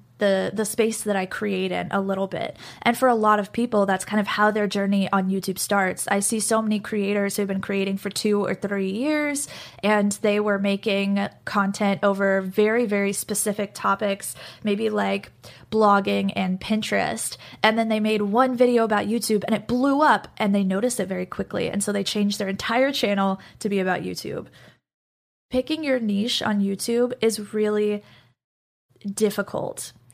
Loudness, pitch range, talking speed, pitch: -23 LUFS, 195-220 Hz, 180 wpm, 205 Hz